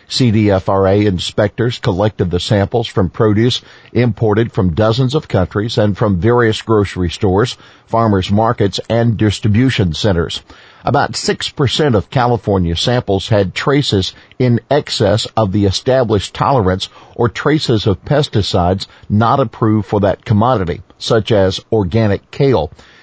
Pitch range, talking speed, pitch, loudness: 100-120 Hz, 125 wpm, 110 Hz, -14 LUFS